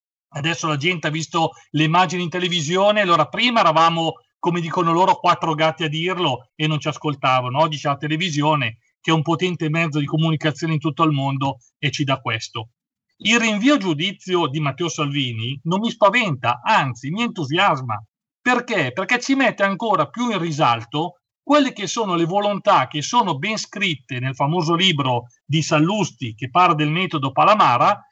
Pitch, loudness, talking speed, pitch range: 165 Hz, -19 LUFS, 175 wpm, 150-185 Hz